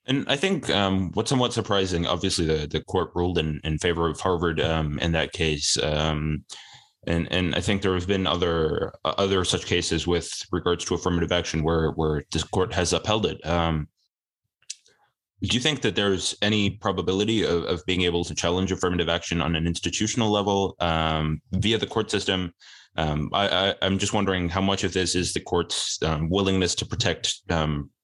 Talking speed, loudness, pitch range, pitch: 190 wpm, -24 LUFS, 80-100 Hz, 90 Hz